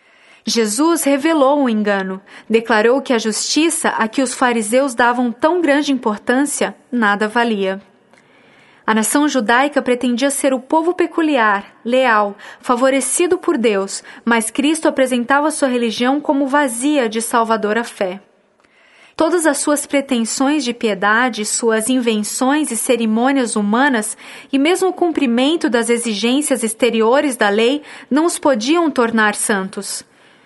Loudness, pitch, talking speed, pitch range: -16 LUFS, 250 Hz, 130 wpm, 225-285 Hz